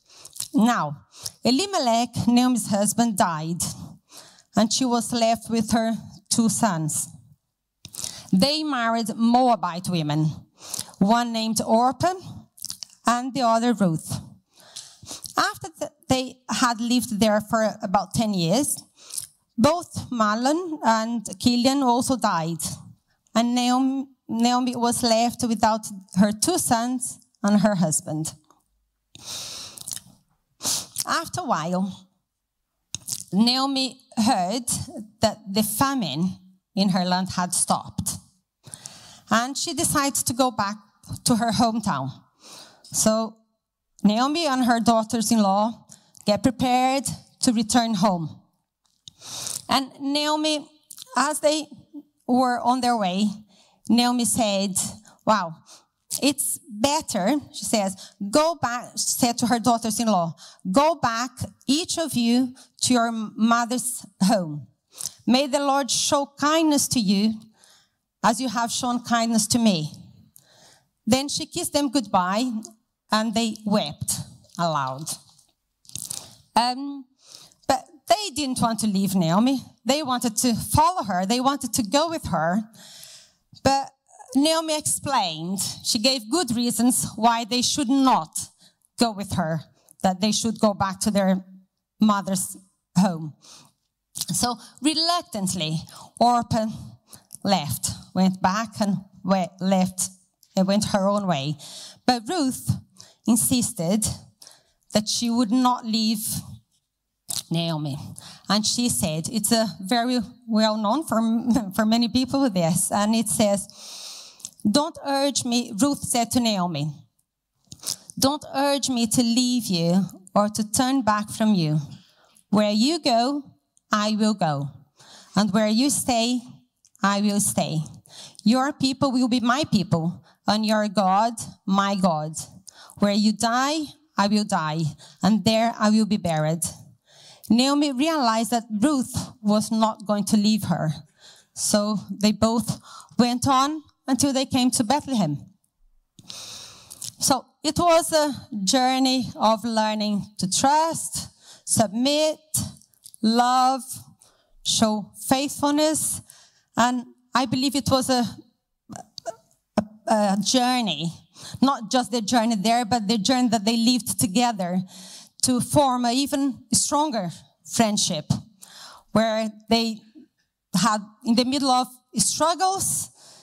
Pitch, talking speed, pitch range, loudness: 225 Hz, 120 wpm, 195-255 Hz, -23 LUFS